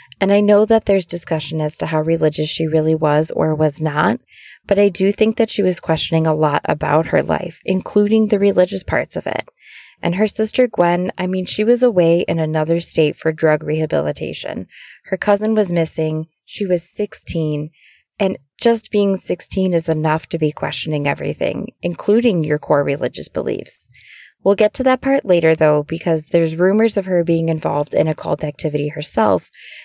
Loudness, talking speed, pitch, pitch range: -16 LUFS, 185 wpm, 165 Hz, 155-200 Hz